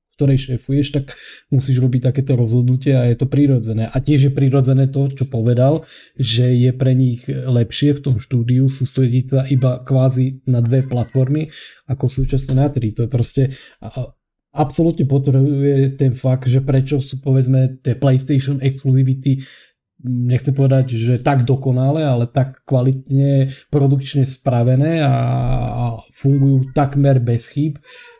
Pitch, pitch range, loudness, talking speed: 130 Hz, 125-140 Hz, -17 LUFS, 140 wpm